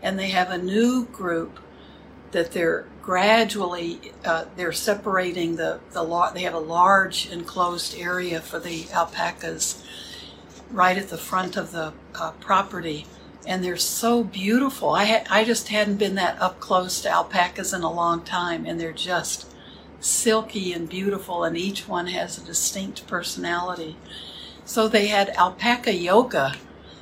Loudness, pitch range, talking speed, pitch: -23 LUFS, 170-200 Hz, 155 wpm, 180 Hz